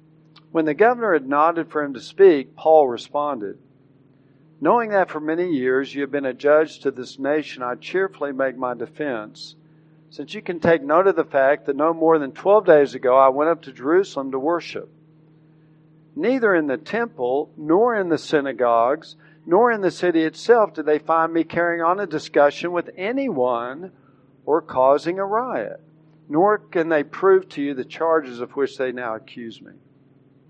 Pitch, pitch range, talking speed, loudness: 155 Hz, 135-170 Hz, 180 wpm, -20 LUFS